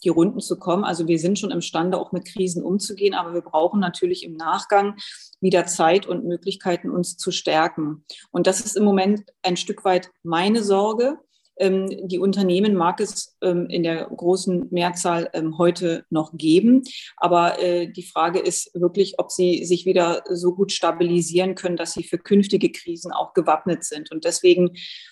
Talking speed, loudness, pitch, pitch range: 165 wpm, -21 LUFS, 180 Hz, 170-195 Hz